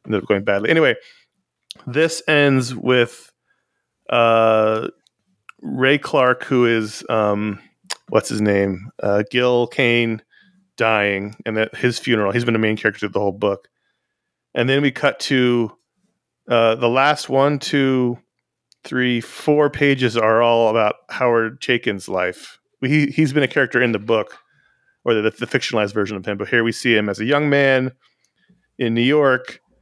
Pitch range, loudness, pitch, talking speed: 110-135 Hz, -18 LUFS, 120 Hz, 160 wpm